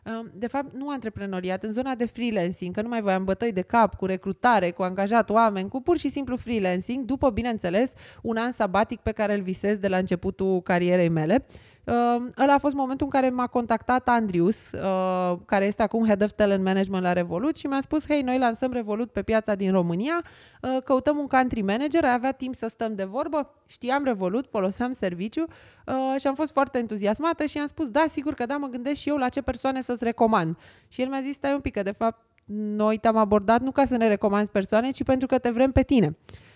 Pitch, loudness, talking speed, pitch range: 235 Hz, -25 LUFS, 220 wpm, 200-265 Hz